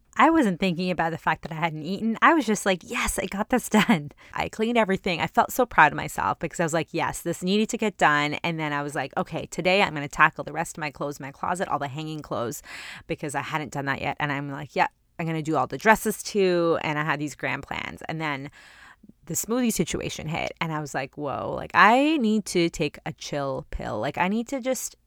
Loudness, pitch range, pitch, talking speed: -25 LUFS, 150-205 Hz, 170 Hz, 260 wpm